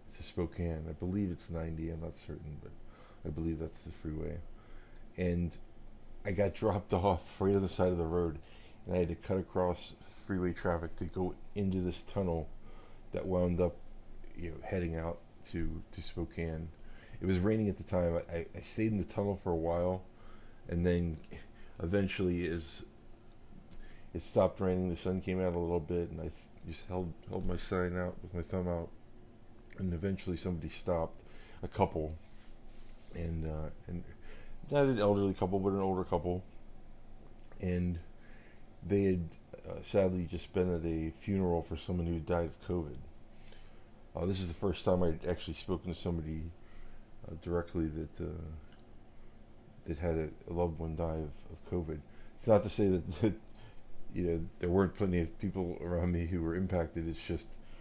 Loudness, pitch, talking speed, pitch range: -36 LUFS, 90 Hz, 175 wpm, 85-100 Hz